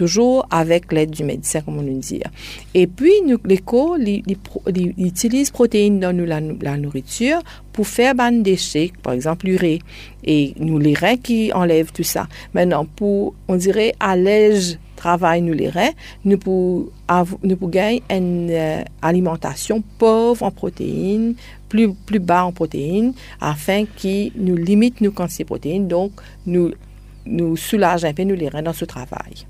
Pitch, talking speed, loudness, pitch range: 185 Hz, 170 wpm, -18 LUFS, 165-210 Hz